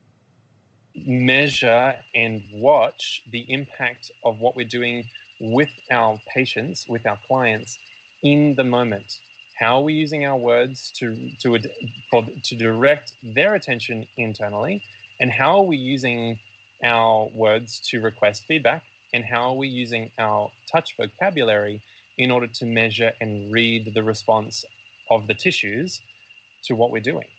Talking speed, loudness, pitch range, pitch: 140 wpm, -16 LUFS, 110-130 Hz, 120 Hz